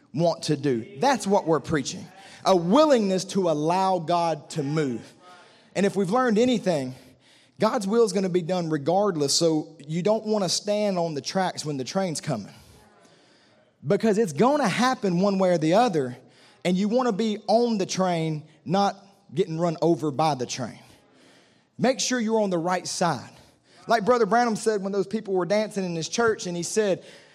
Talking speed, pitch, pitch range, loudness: 190 wpm, 185 Hz, 160-215 Hz, -24 LUFS